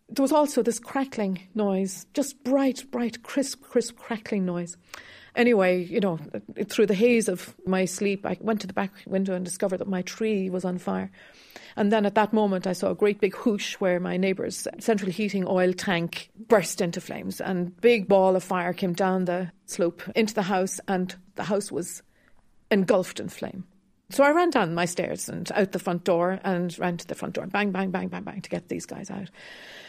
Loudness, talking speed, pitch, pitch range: -26 LUFS, 210 wpm, 195 Hz, 185-220 Hz